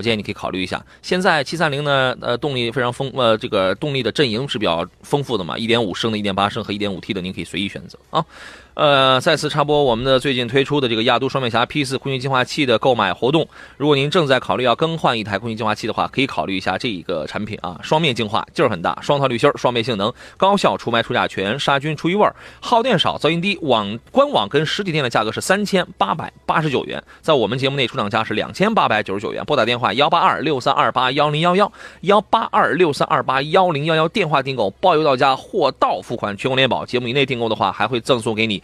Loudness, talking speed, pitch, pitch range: -18 LUFS, 385 characters per minute, 130 Hz, 110-150 Hz